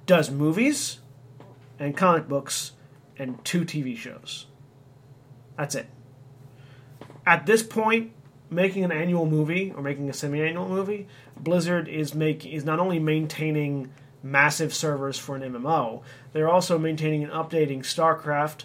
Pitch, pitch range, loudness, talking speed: 150 Hz, 135-165 Hz, -25 LUFS, 135 wpm